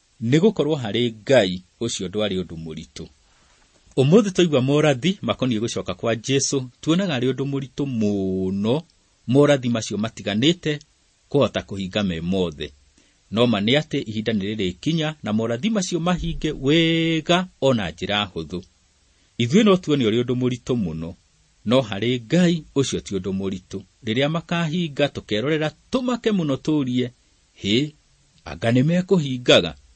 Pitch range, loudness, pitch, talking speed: 100-155 Hz, -21 LUFS, 125 Hz, 120 wpm